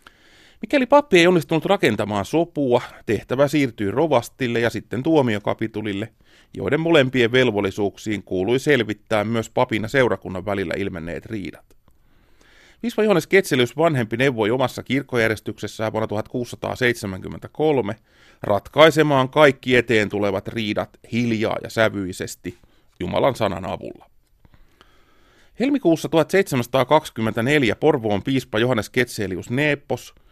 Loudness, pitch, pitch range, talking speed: -20 LUFS, 120 Hz, 105-145 Hz, 100 wpm